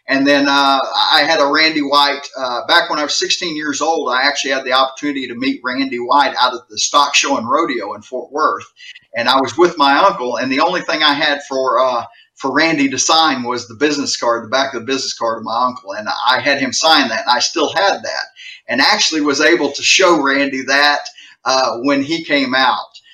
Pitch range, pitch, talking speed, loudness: 130-160 Hz, 140 Hz, 235 wpm, -14 LUFS